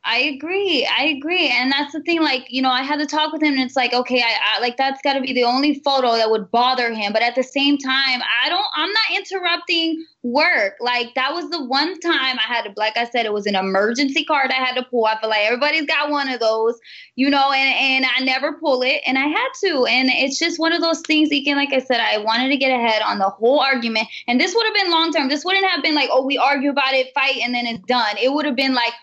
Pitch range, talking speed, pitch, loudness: 245-310 Hz, 280 wpm, 270 Hz, -18 LUFS